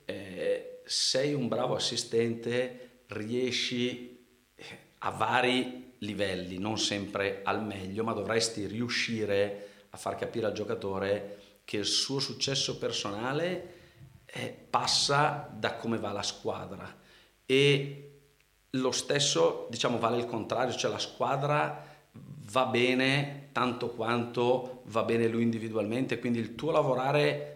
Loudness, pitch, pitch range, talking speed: -30 LUFS, 120 Hz, 105-130 Hz, 115 wpm